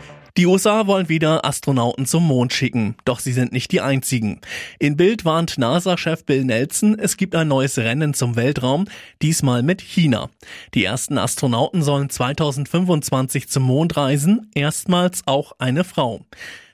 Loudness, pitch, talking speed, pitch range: -19 LUFS, 145 Hz, 150 wpm, 130-170 Hz